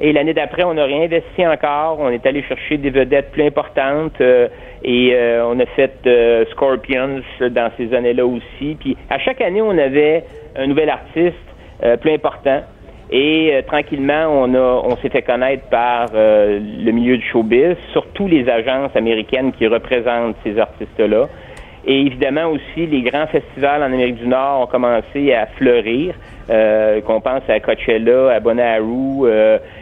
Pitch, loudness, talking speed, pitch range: 130 Hz, -15 LUFS, 170 wpm, 120-150 Hz